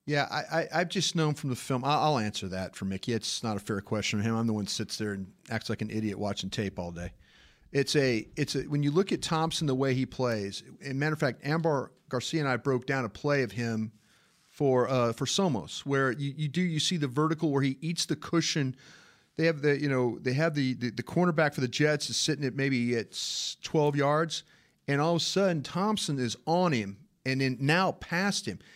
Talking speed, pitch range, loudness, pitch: 240 wpm, 115-155 Hz, -29 LUFS, 135 Hz